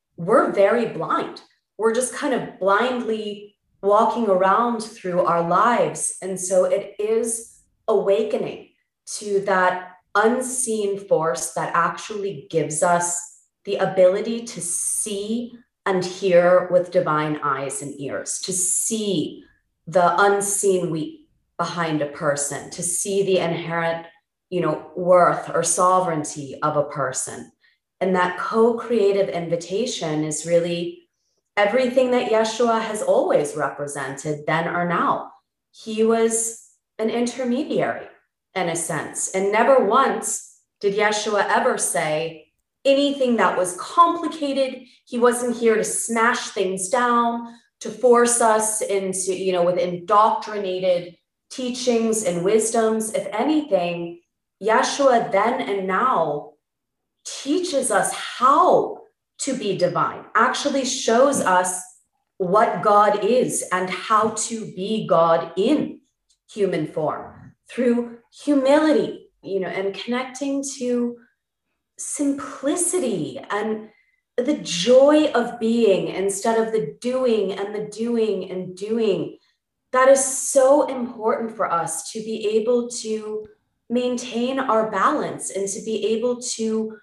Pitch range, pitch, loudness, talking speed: 180-240 Hz, 210 Hz, -21 LUFS, 120 wpm